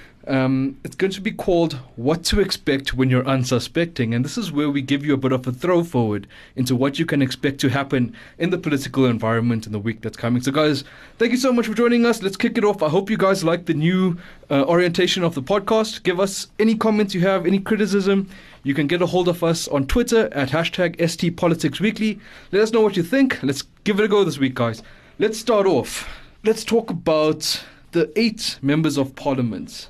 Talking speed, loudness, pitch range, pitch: 225 wpm, -20 LUFS, 135-200 Hz, 165 Hz